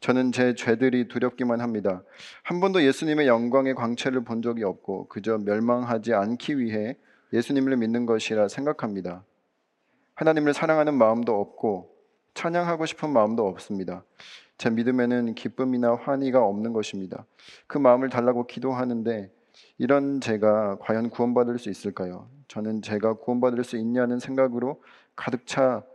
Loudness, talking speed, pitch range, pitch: -25 LUFS, 335 characters per minute, 110-130 Hz, 120 Hz